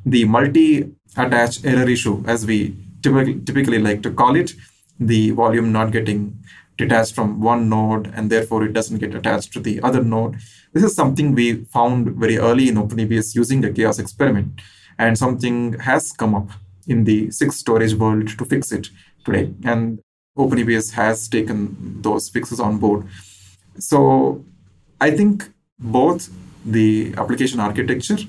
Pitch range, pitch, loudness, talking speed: 105-120 Hz, 115 Hz, -18 LUFS, 155 wpm